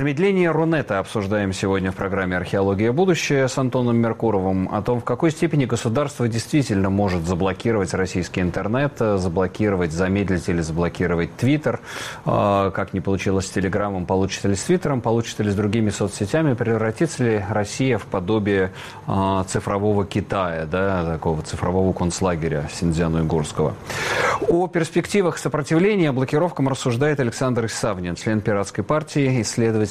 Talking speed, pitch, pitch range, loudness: 130 wpm, 105 Hz, 95-130 Hz, -21 LUFS